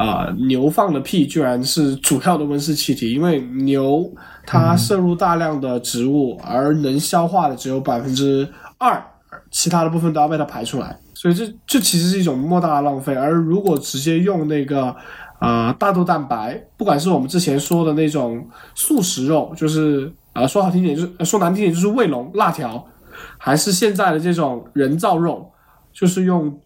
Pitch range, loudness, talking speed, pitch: 140-175 Hz, -18 LUFS, 280 characters per minute, 155 Hz